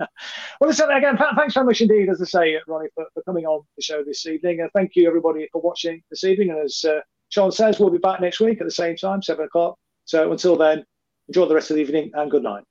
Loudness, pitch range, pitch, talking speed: -20 LUFS, 155-195 Hz, 170 Hz, 260 wpm